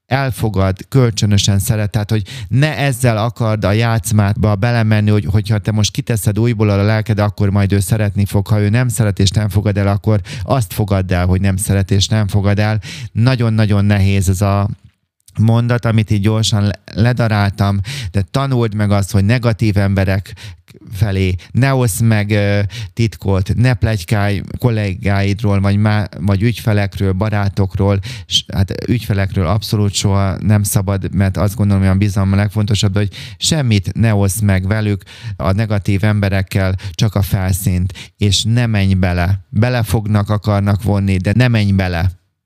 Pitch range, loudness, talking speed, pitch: 100-110 Hz, -15 LUFS, 160 wpm, 105 Hz